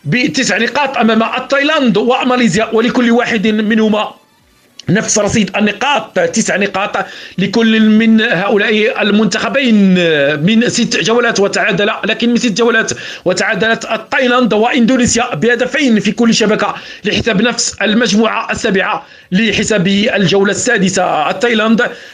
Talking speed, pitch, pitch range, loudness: 110 wpm, 220 Hz, 205-235 Hz, -12 LUFS